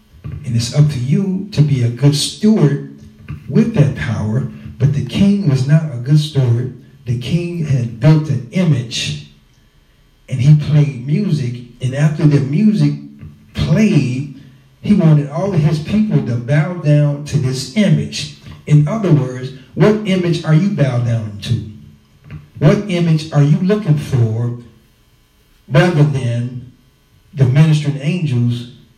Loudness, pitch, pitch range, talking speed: -15 LUFS, 145 Hz, 120-155 Hz, 145 wpm